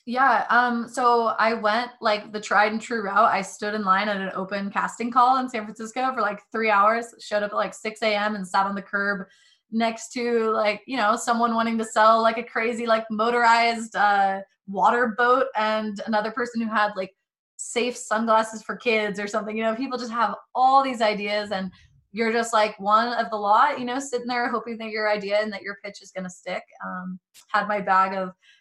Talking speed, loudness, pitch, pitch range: 220 wpm, -23 LUFS, 220 Hz, 205-235 Hz